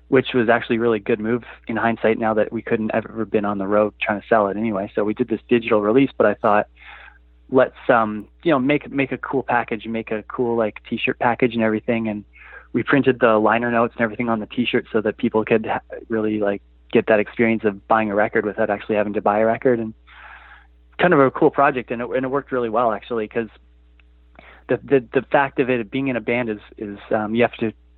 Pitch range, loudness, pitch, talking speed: 105-120 Hz, -20 LUFS, 115 Hz, 240 wpm